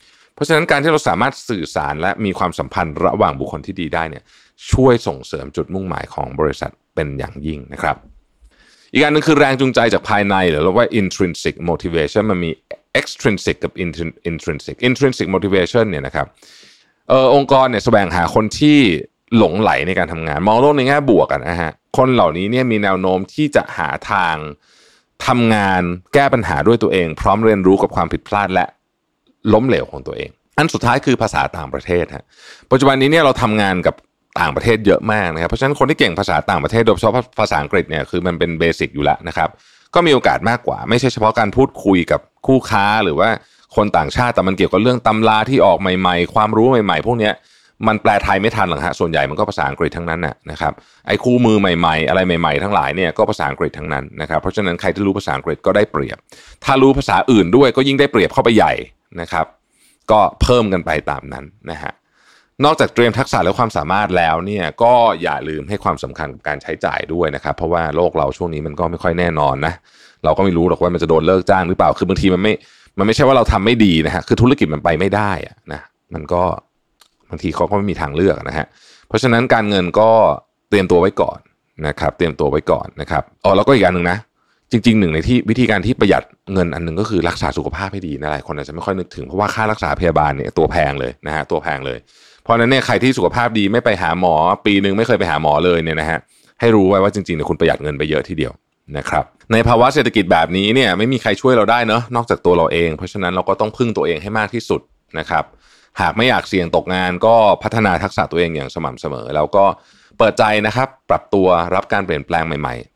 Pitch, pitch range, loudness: 100 Hz, 85-115 Hz, -16 LUFS